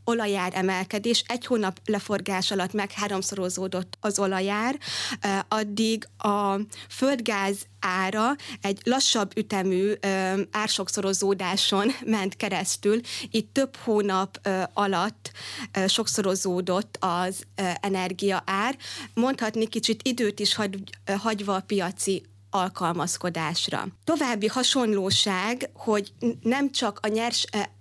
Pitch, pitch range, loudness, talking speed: 205 Hz, 190-225 Hz, -26 LUFS, 90 wpm